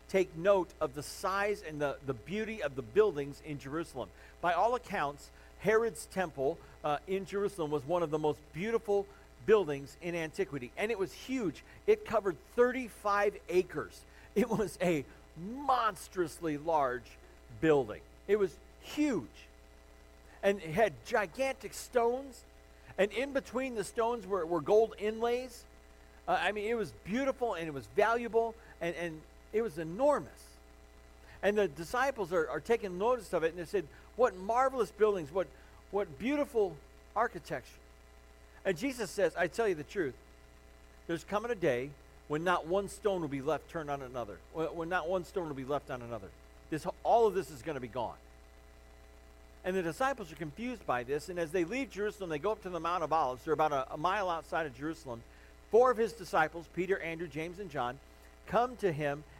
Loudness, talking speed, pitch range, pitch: -34 LUFS, 180 wpm, 140-215 Hz, 175 Hz